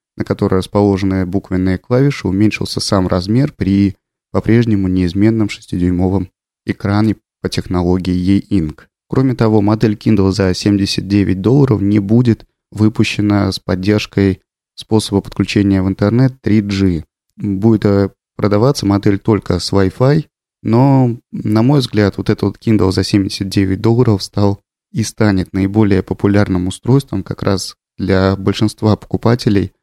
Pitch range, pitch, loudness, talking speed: 95-110 Hz, 100 Hz, -14 LUFS, 120 wpm